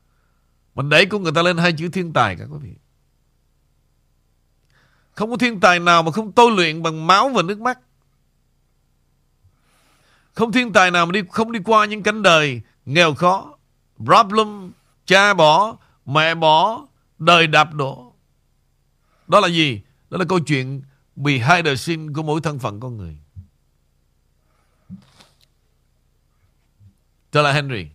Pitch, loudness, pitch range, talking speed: 160 Hz, -16 LUFS, 135-190 Hz, 150 wpm